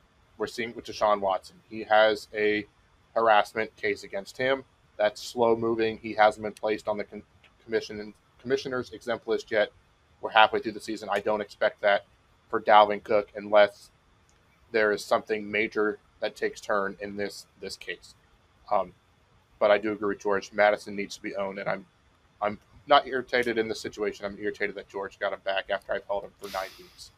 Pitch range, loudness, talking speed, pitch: 100-110 Hz, -27 LUFS, 190 wpm, 105 Hz